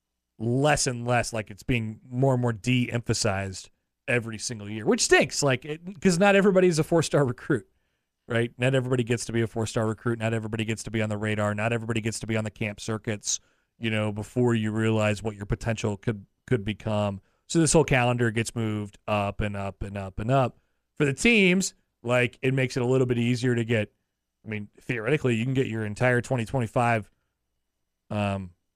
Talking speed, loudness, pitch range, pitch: 205 wpm, -26 LUFS, 105-125 Hz, 115 Hz